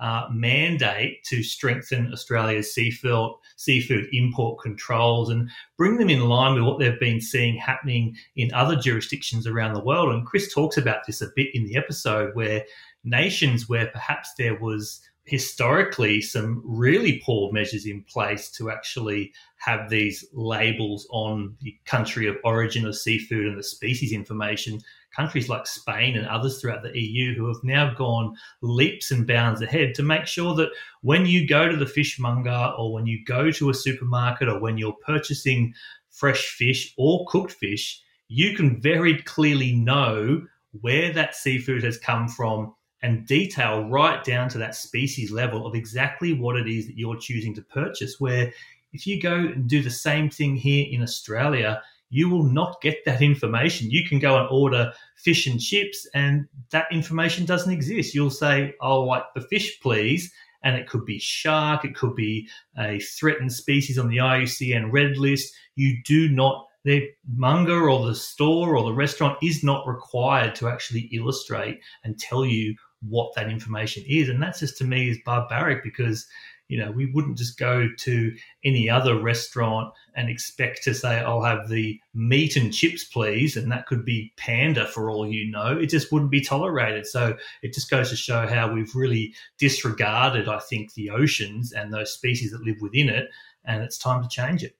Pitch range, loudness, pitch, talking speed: 115-140 Hz, -23 LUFS, 125 Hz, 180 wpm